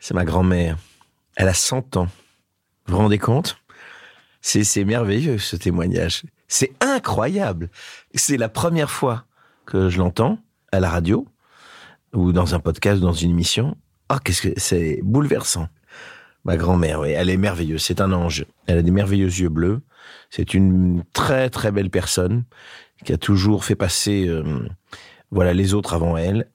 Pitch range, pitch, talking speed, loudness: 90-105 Hz, 95 Hz, 165 wpm, -20 LUFS